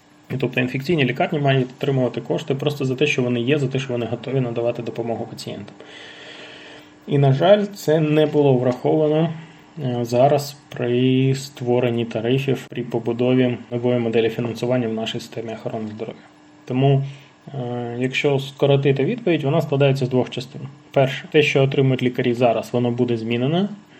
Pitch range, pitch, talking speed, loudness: 120-145 Hz, 130 Hz, 150 wpm, -20 LUFS